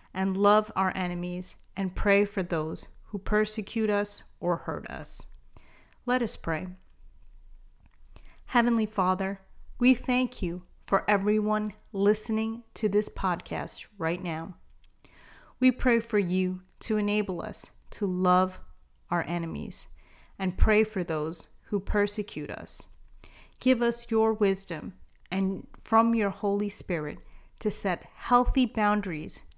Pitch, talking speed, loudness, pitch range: 200 Hz, 125 wpm, -28 LUFS, 175-215 Hz